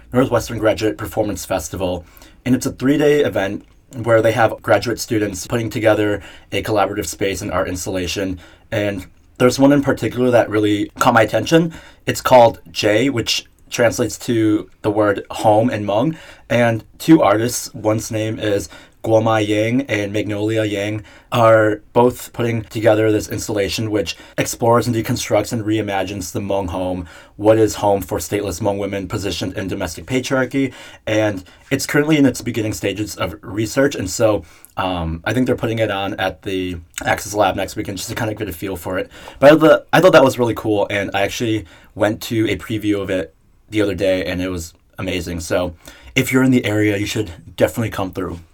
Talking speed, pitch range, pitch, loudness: 185 wpm, 95-115 Hz, 105 Hz, -18 LUFS